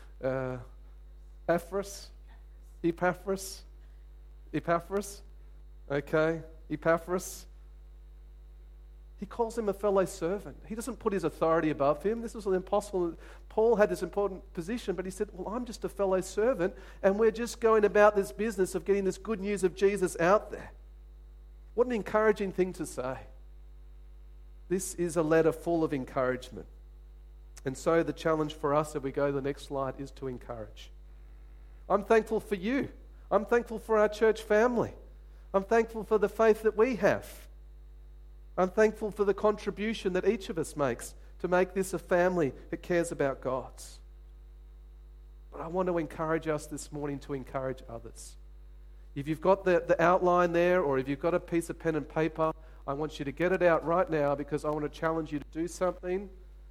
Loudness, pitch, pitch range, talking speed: -30 LUFS, 165 Hz, 120-195 Hz, 175 wpm